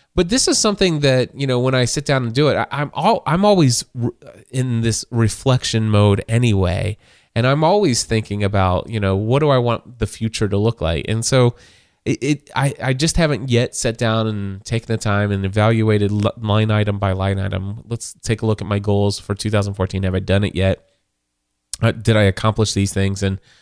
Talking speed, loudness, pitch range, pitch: 215 wpm, -18 LUFS, 100-130 Hz, 110 Hz